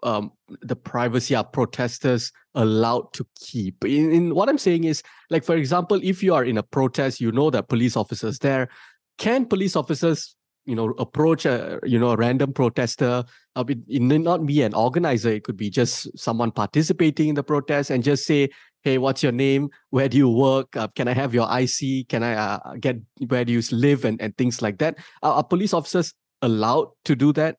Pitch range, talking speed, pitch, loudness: 120-155 Hz, 205 wpm, 135 Hz, -22 LUFS